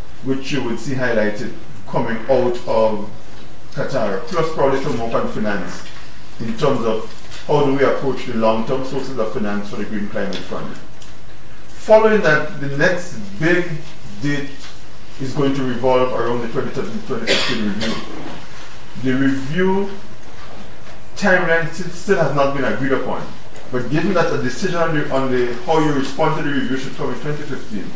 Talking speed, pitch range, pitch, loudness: 160 wpm, 125-160 Hz, 135 Hz, -19 LUFS